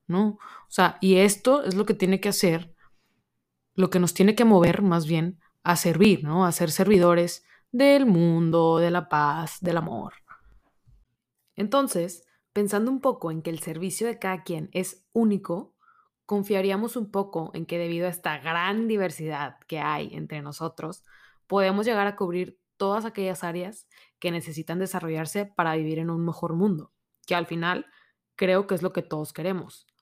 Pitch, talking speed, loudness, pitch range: 180 Hz, 170 wpm, -25 LUFS, 165-200 Hz